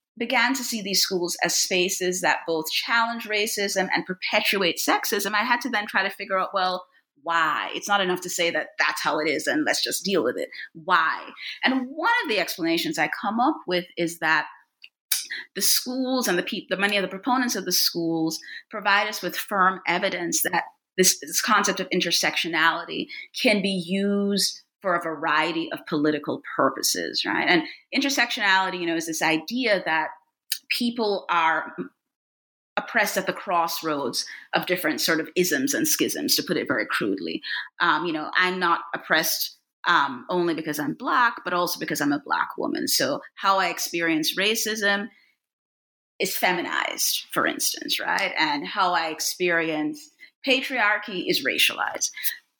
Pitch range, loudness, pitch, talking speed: 170-235 Hz, -23 LUFS, 190 Hz, 165 wpm